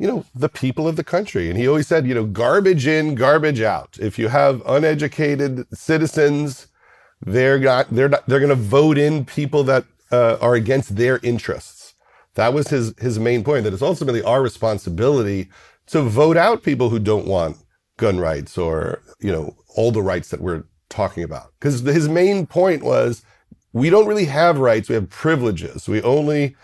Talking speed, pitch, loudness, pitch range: 190 wpm, 140 Hz, -18 LUFS, 115-155 Hz